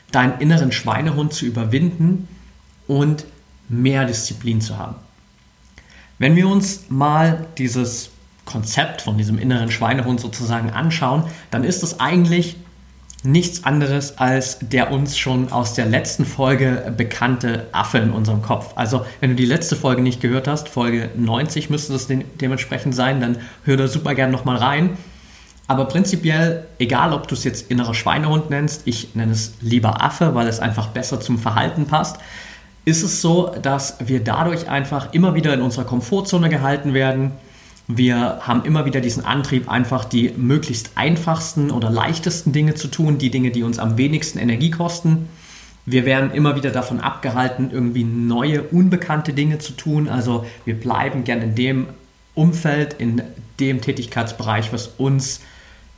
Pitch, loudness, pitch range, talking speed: 130 Hz, -19 LUFS, 120-150 Hz, 160 wpm